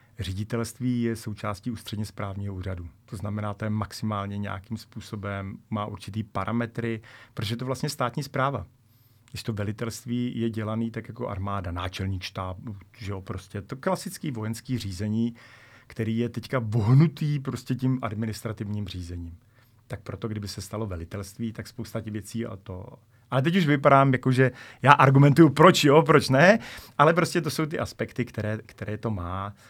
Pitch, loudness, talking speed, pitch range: 115 Hz, -26 LUFS, 165 wpm, 105-125 Hz